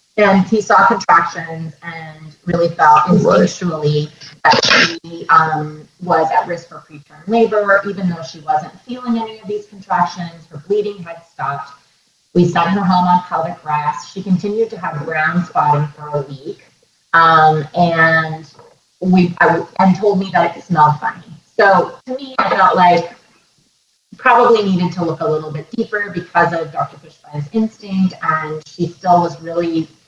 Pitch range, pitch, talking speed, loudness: 155-190 Hz, 170 Hz, 165 wpm, -14 LUFS